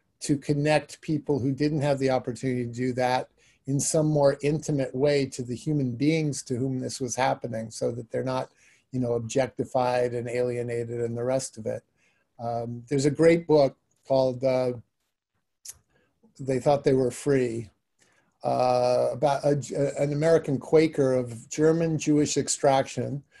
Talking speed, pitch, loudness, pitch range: 160 wpm, 135 Hz, -26 LUFS, 125-145 Hz